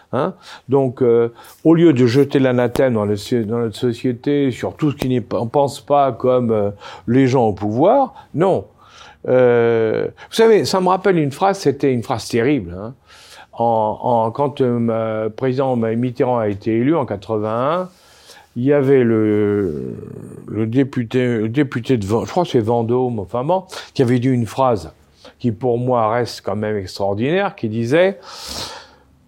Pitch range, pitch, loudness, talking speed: 115-140 Hz, 125 Hz, -17 LUFS, 170 wpm